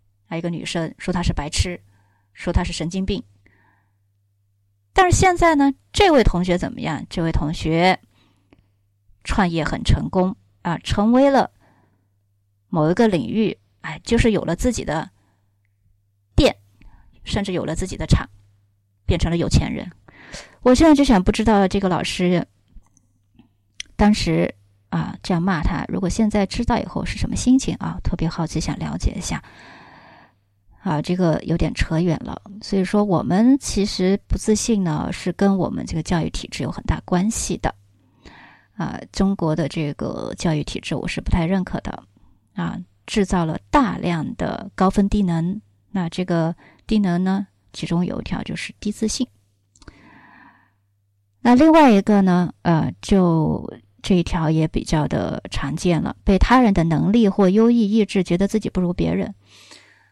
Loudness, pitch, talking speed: -20 LUFS, 170 Hz, 230 characters per minute